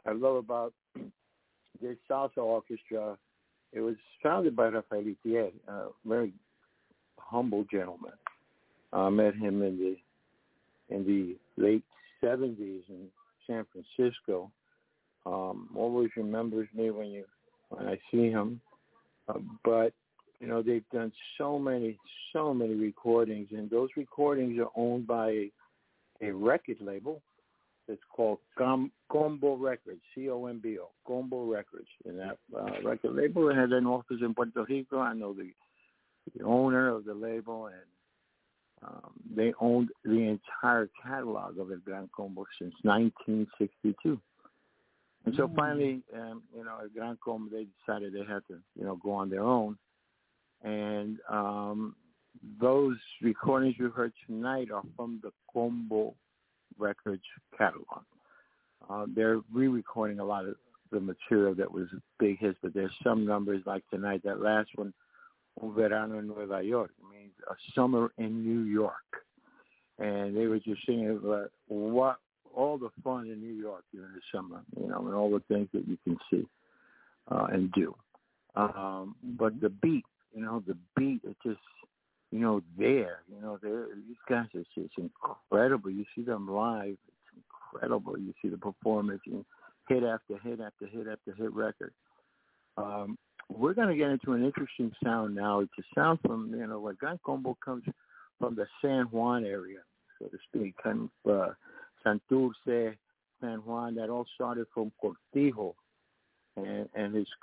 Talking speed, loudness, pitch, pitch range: 155 wpm, -33 LUFS, 110 Hz, 105-125 Hz